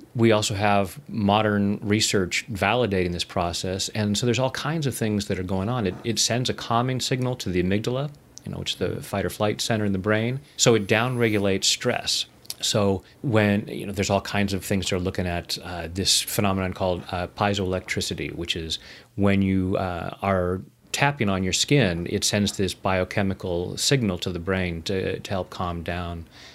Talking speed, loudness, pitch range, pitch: 195 wpm, -24 LUFS, 95-110 Hz, 100 Hz